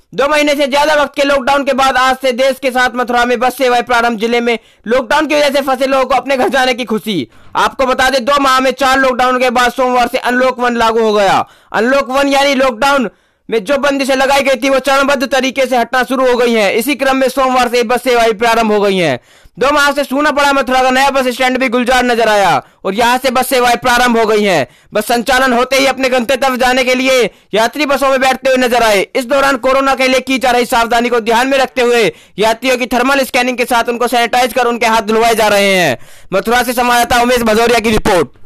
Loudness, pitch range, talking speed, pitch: -11 LUFS, 240-270 Hz, 245 wpm, 255 Hz